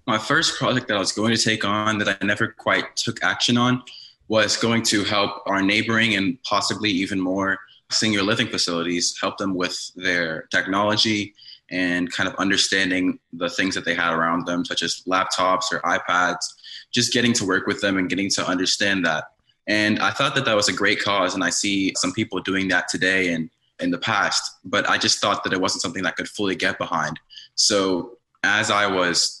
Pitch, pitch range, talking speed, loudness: 100 Hz, 90-110 Hz, 205 wpm, -21 LUFS